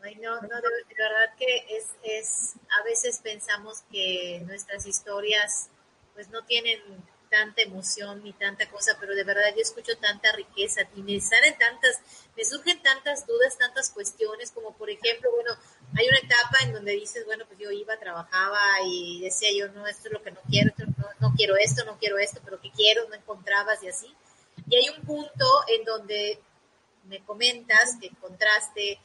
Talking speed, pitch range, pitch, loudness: 185 wpm, 200-240 Hz, 215 Hz, -24 LUFS